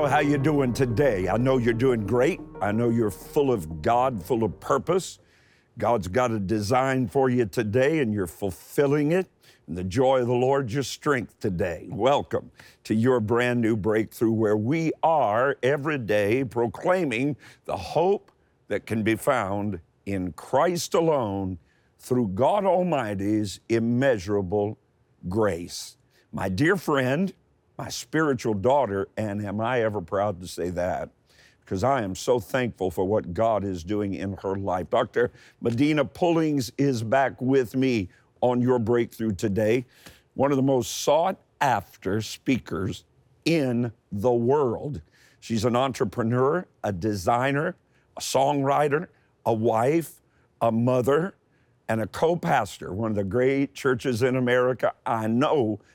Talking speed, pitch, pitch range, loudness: 145 wpm, 120 Hz, 105-135 Hz, -25 LUFS